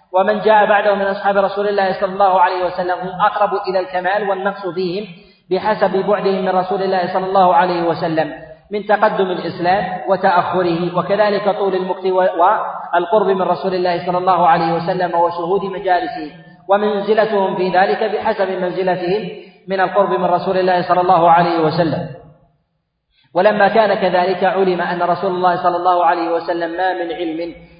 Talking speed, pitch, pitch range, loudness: 155 wpm, 185 Hz, 175-195 Hz, -16 LUFS